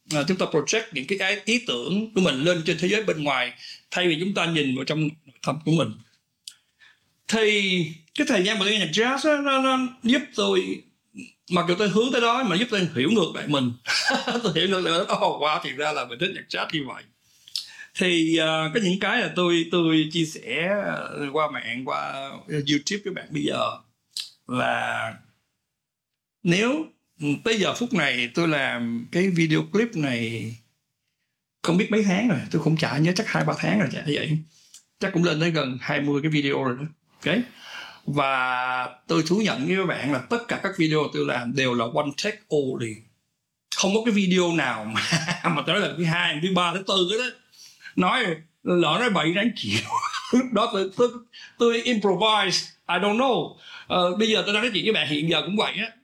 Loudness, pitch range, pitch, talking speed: -23 LUFS, 150-215 Hz, 175 Hz, 200 wpm